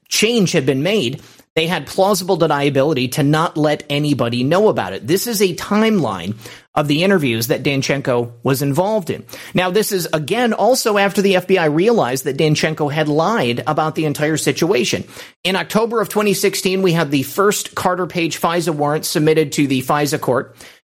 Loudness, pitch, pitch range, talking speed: -17 LUFS, 160 Hz, 145-190 Hz, 175 wpm